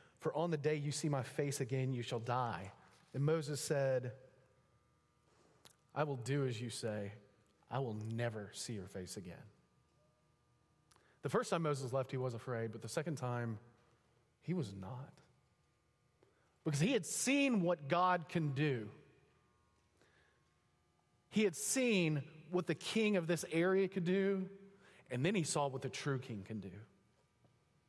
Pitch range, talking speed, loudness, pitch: 120-170 Hz, 155 wpm, -38 LUFS, 140 Hz